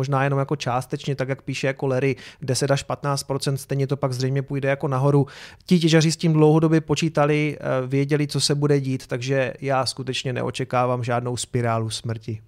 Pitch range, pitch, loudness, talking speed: 130-145 Hz, 135 Hz, -22 LUFS, 180 wpm